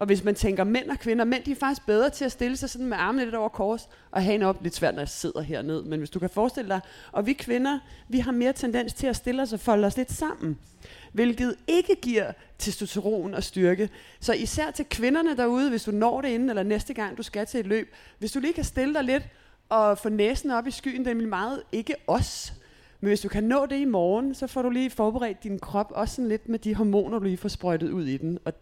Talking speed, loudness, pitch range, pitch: 260 wpm, -27 LUFS, 200-260 Hz, 225 Hz